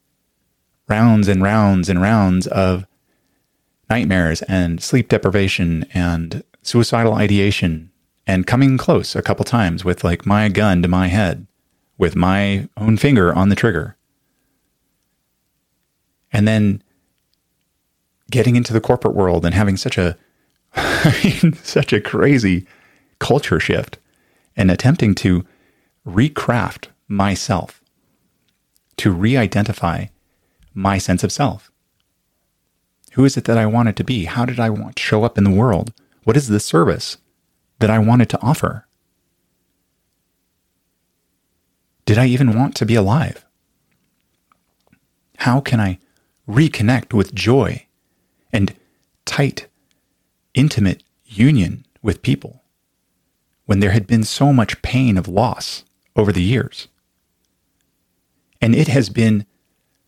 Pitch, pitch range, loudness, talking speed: 100 Hz, 90-115 Hz, -17 LUFS, 120 wpm